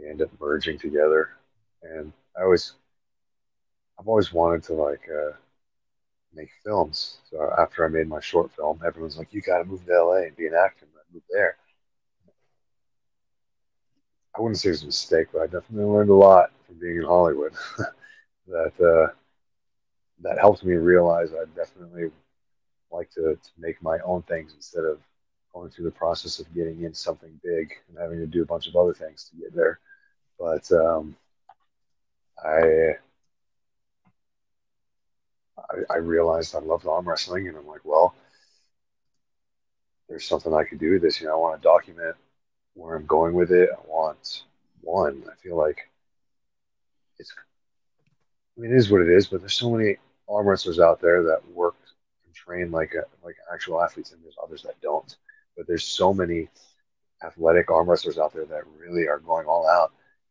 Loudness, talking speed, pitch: -23 LUFS, 170 wpm, 90 Hz